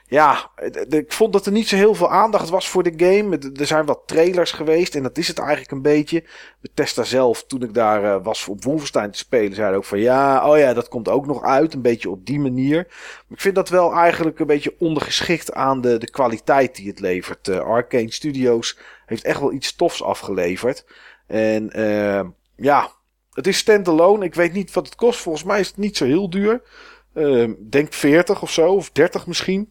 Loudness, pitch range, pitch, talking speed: -18 LUFS, 130-190 Hz, 160 Hz, 220 wpm